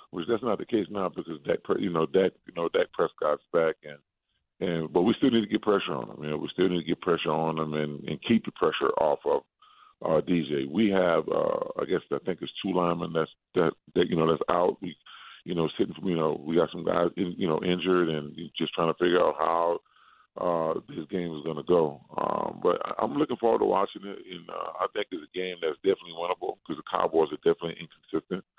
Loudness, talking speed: -28 LUFS, 245 wpm